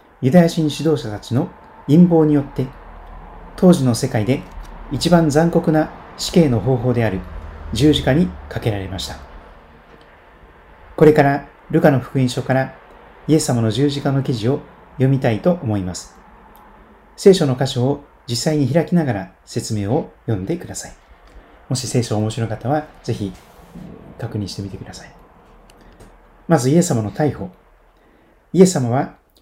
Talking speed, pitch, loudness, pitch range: 285 characters per minute, 135 Hz, -18 LUFS, 115-160 Hz